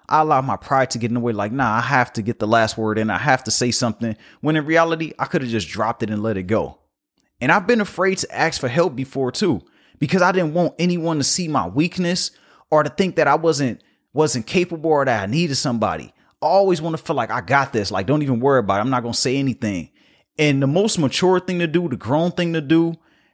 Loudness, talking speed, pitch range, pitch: -19 LUFS, 260 wpm, 120-165 Hz, 140 Hz